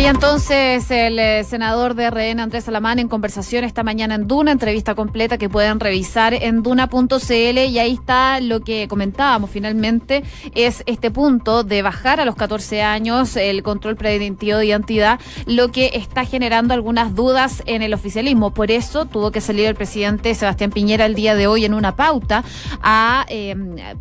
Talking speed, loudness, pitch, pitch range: 170 wpm, -17 LUFS, 225 Hz, 215-245 Hz